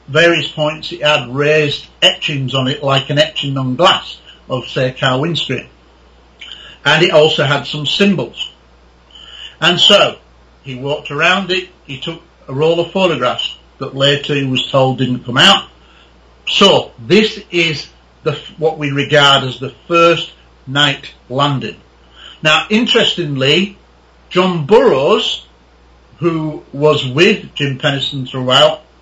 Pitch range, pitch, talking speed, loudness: 125-160 Hz, 145 Hz, 135 wpm, -13 LUFS